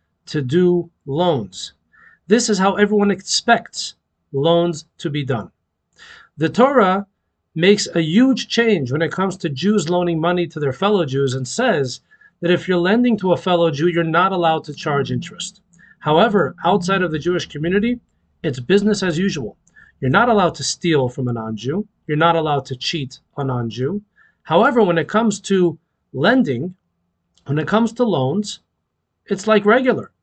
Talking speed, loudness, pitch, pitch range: 170 wpm, -18 LUFS, 175 Hz, 150-205 Hz